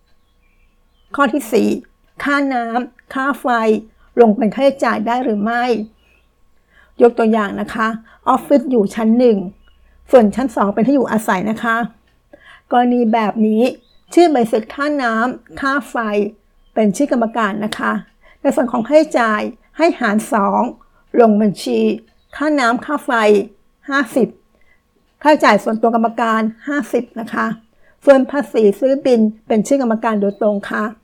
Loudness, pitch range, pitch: -16 LUFS, 220-270 Hz, 230 Hz